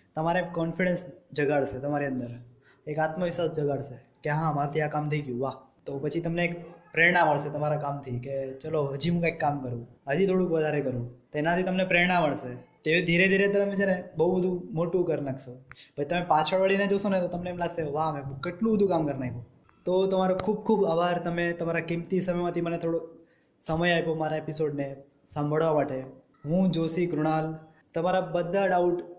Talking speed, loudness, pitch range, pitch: 185 wpm, -27 LUFS, 145-175 Hz, 165 Hz